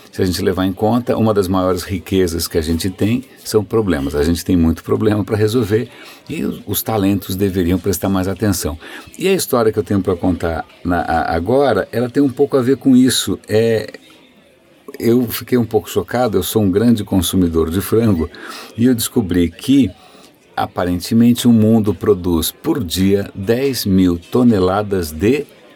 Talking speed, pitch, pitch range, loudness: 175 wpm, 100 Hz, 90-115 Hz, -16 LUFS